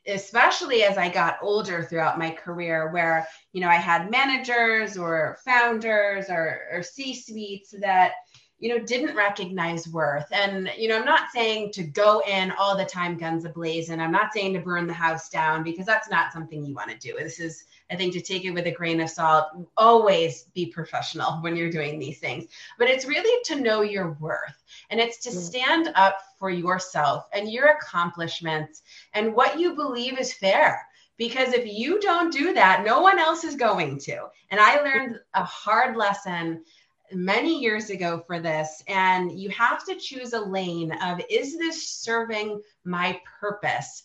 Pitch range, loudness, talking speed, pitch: 170-230 Hz, -24 LUFS, 185 wpm, 195 Hz